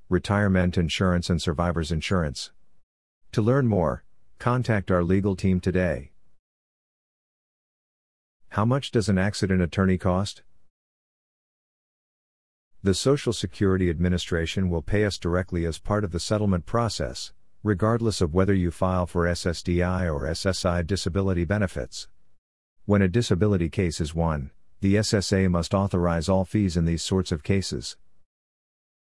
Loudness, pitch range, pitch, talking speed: -25 LUFS, 85-100 Hz, 90 Hz, 130 wpm